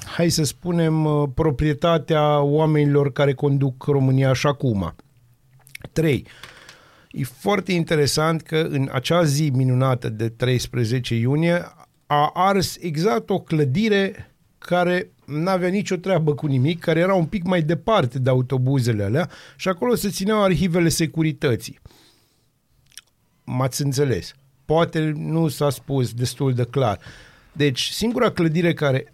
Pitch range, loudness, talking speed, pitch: 130-170 Hz, -21 LUFS, 130 wpm, 150 Hz